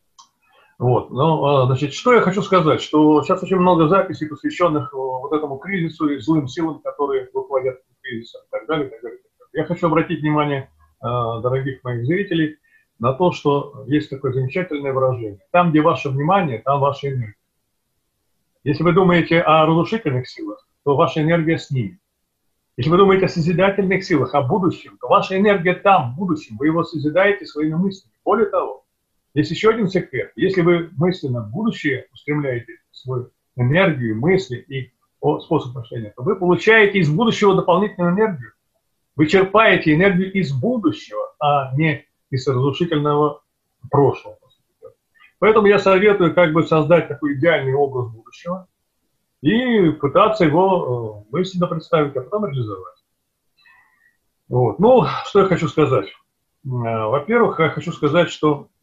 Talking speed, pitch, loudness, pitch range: 145 wpm, 155 Hz, -18 LUFS, 135-185 Hz